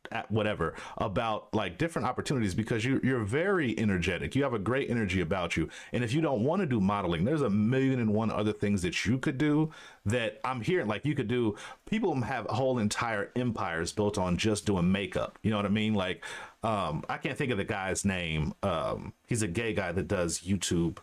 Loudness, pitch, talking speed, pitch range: -30 LUFS, 105 Hz, 215 wpm, 100-125 Hz